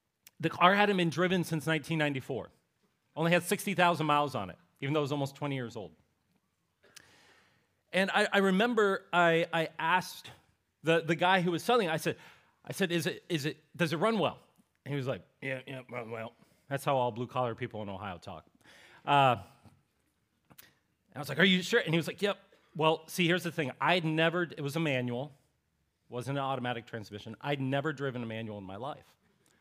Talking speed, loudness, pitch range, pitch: 205 wpm, -31 LUFS, 125-175 Hz, 150 Hz